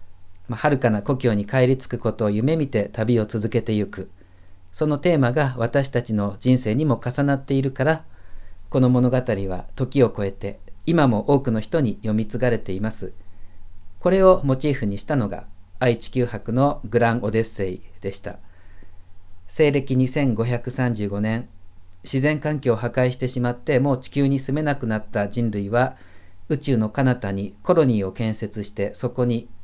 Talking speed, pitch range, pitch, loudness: 300 characters per minute, 100-130 Hz, 115 Hz, -22 LUFS